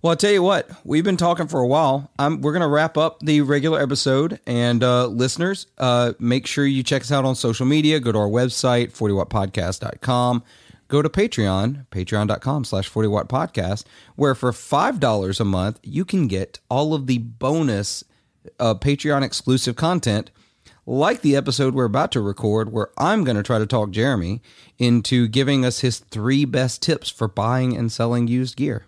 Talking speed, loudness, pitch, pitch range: 185 wpm, -20 LUFS, 125 Hz, 110-145 Hz